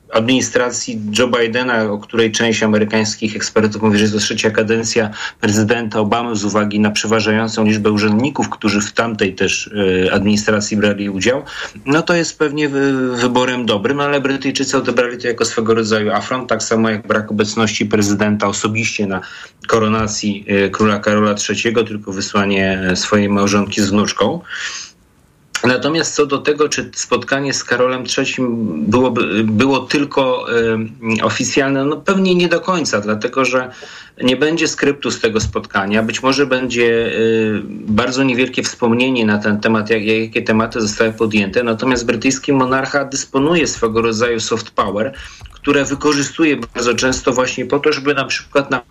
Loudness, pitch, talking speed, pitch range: -16 LUFS, 115 Hz, 155 wpm, 110-130 Hz